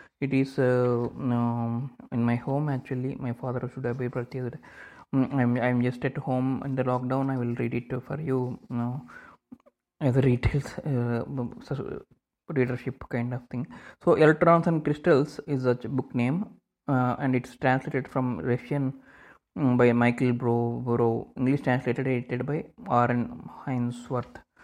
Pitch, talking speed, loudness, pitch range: 125 Hz, 150 wpm, -27 LUFS, 120-135 Hz